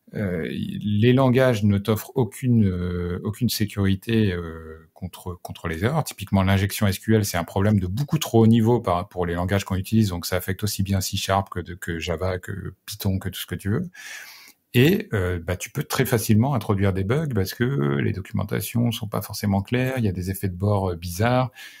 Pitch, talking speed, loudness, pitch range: 100 Hz, 210 wpm, -23 LUFS, 90-115 Hz